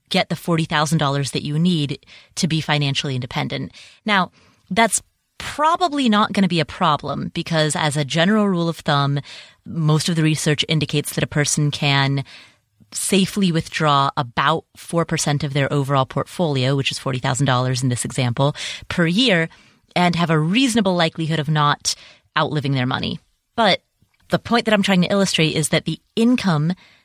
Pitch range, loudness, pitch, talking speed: 140-175 Hz, -19 LUFS, 155 Hz, 160 wpm